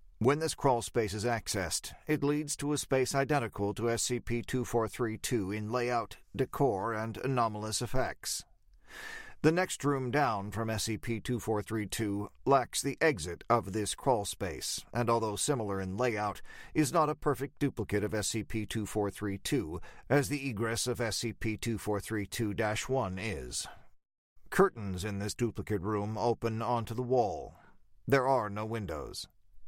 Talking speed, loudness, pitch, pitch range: 140 wpm, -33 LUFS, 115 Hz, 105-130 Hz